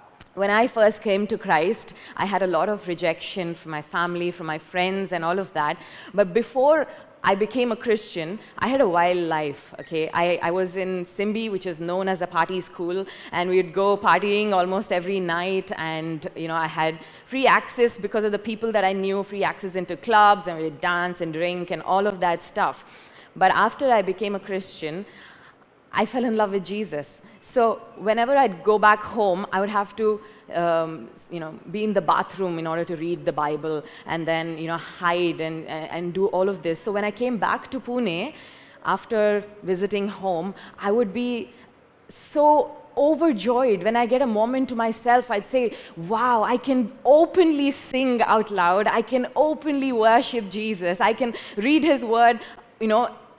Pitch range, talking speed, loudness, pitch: 175-230 Hz, 195 wpm, -23 LUFS, 200 Hz